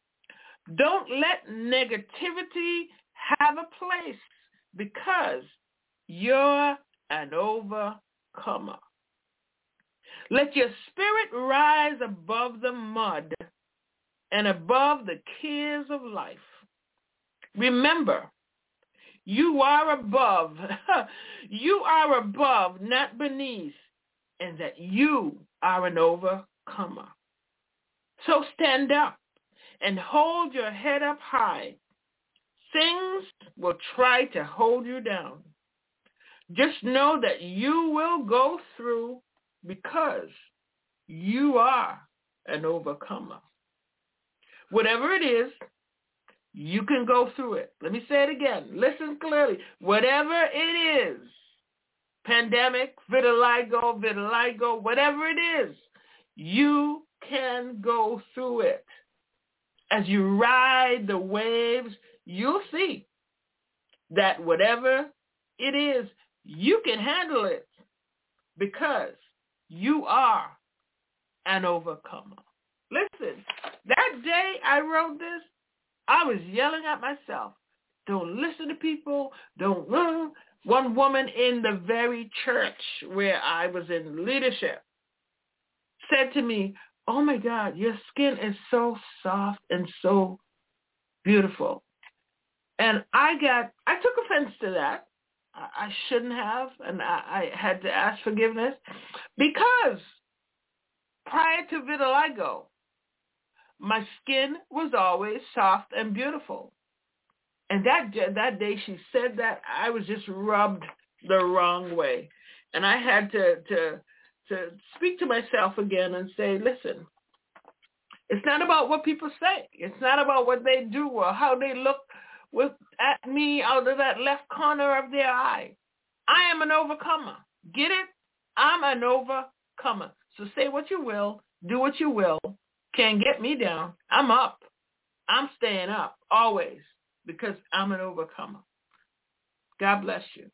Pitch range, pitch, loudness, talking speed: 215-300 Hz, 260 Hz, -25 LUFS, 115 wpm